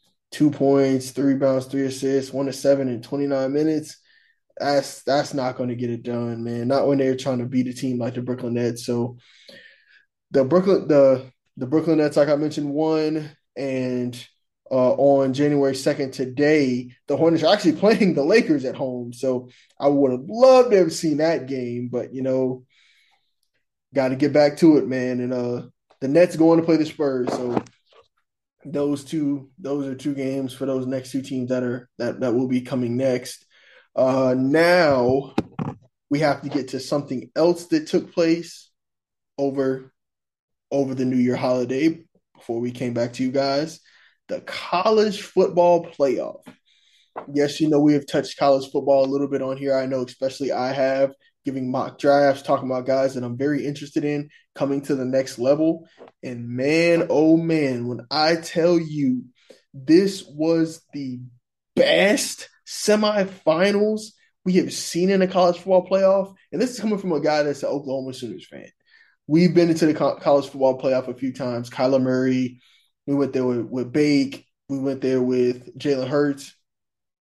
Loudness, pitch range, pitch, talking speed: -21 LUFS, 130-155 Hz, 140 Hz, 180 wpm